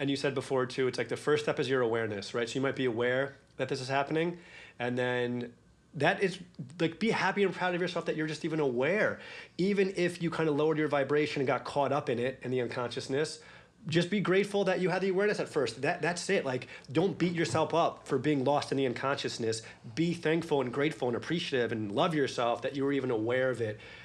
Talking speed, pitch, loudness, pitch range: 240 wpm, 145 Hz, -31 LUFS, 130-165 Hz